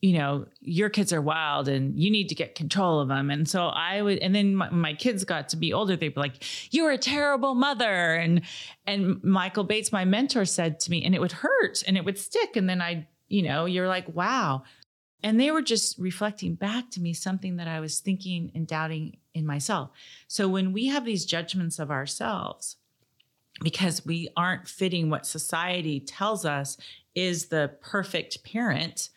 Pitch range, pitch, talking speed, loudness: 160-200 Hz, 175 Hz, 195 wpm, -27 LUFS